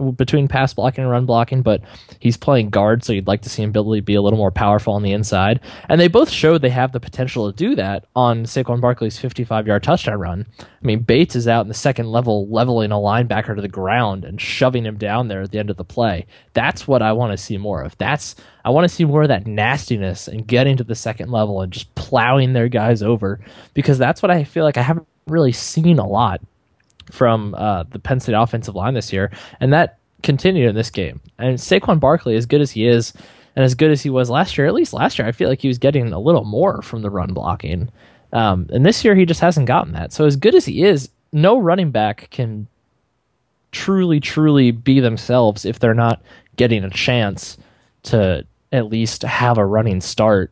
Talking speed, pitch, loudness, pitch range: 230 wpm, 120 Hz, -17 LUFS, 105-130 Hz